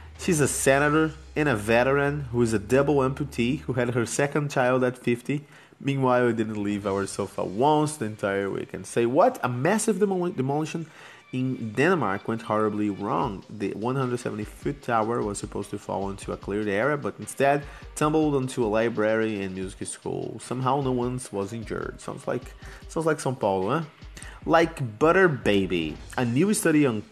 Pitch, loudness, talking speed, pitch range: 125 Hz, -25 LUFS, 175 wpm, 105-145 Hz